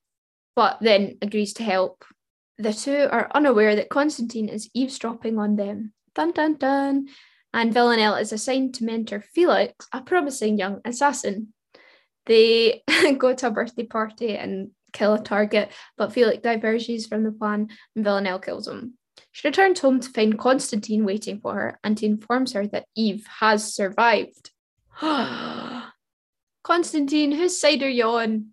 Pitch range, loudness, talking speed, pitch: 215-275 Hz, -22 LUFS, 150 wpm, 230 Hz